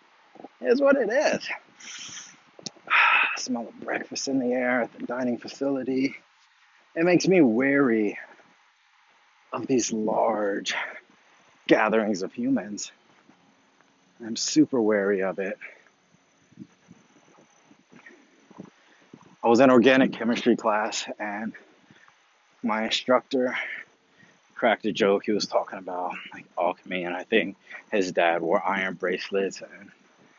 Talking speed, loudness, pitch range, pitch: 115 wpm, -24 LUFS, 105-140 Hz, 125 Hz